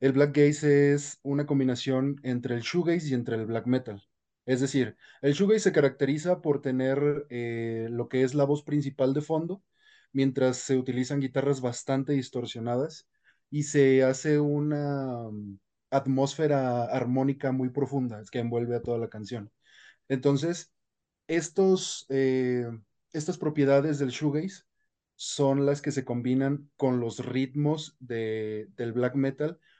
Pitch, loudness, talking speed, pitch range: 135 Hz, -28 LUFS, 145 wpm, 125-145 Hz